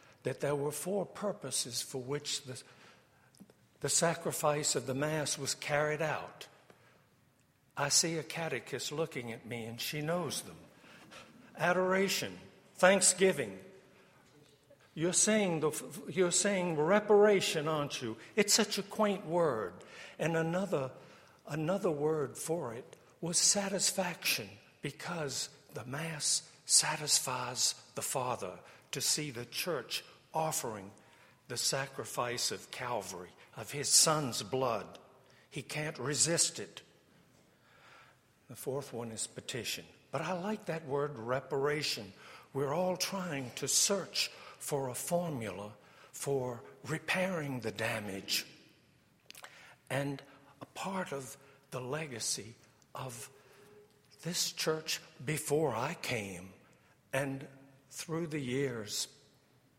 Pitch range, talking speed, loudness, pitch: 135-175 Hz, 110 wpm, -33 LUFS, 150 Hz